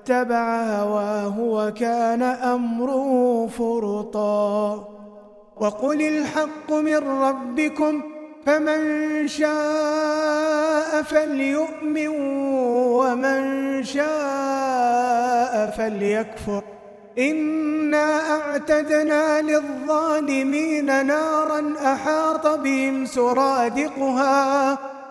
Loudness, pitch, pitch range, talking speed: -21 LUFS, 275 Hz, 240-305 Hz, 55 wpm